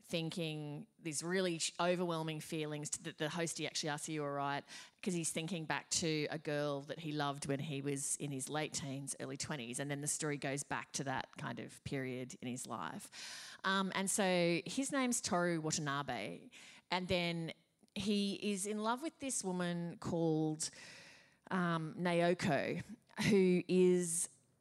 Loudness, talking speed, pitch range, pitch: -38 LUFS, 165 wpm, 145-185 Hz, 165 Hz